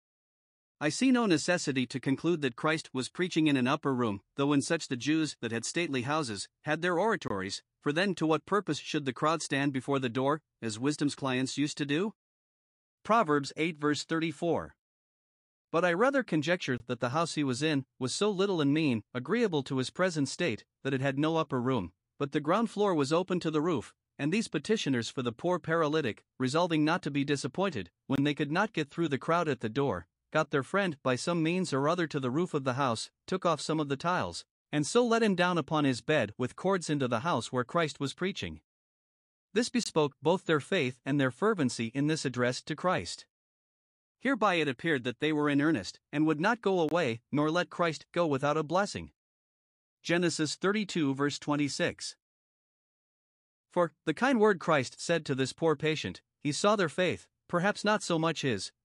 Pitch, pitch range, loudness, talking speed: 155 Hz, 135-175 Hz, -30 LUFS, 205 wpm